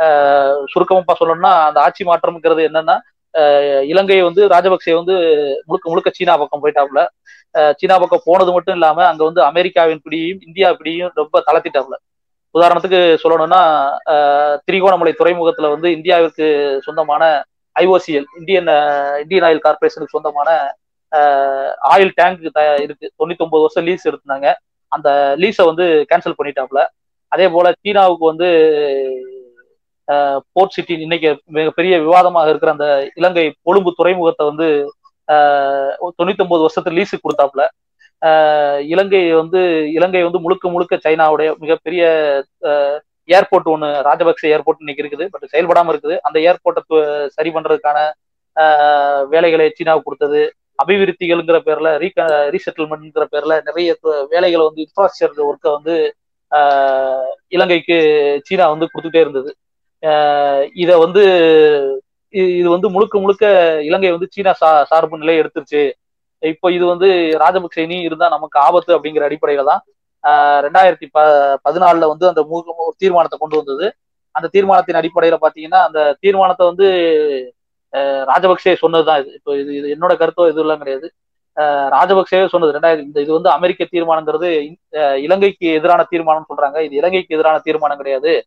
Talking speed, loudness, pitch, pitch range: 125 wpm, -13 LUFS, 165 Hz, 150-180 Hz